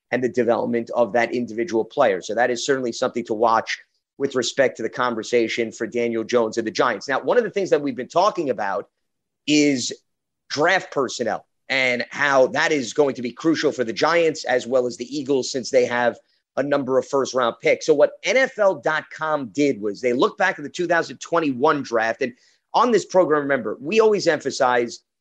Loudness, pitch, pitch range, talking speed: -21 LUFS, 130 Hz, 120-150 Hz, 200 wpm